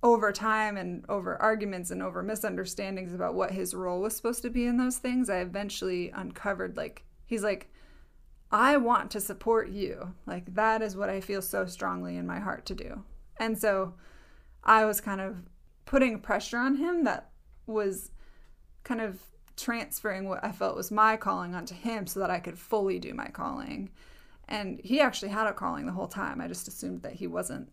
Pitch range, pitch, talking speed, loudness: 190-225 Hz, 210 Hz, 195 wpm, -30 LUFS